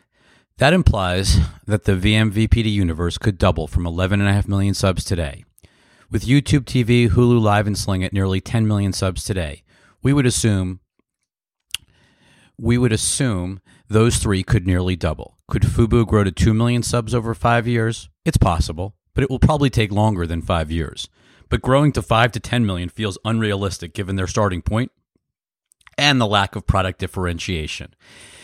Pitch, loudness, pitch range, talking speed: 105 Hz, -19 LUFS, 95-115 Hz, 170 wpm